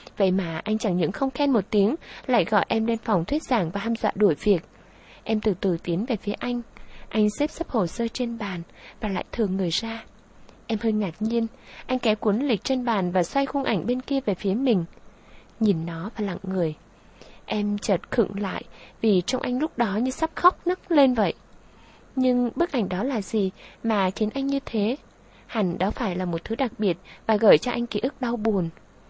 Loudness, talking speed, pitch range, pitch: -25 LUFS, 220 wpm, 195-245 Hz, 220 Hz